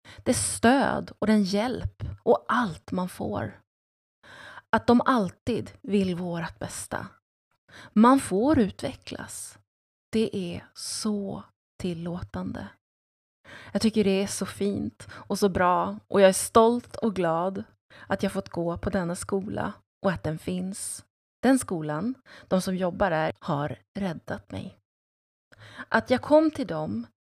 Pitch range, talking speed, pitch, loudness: 125-210 Hz, 140 wpm, 190 Hz, -26 LUFS